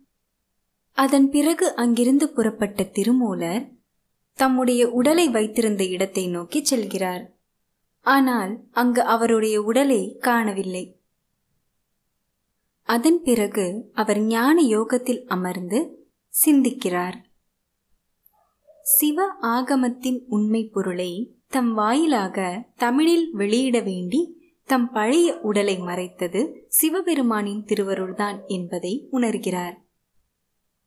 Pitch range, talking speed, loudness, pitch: 200-270 Hz, 80 wpm, -21 LUFS, 235 Hz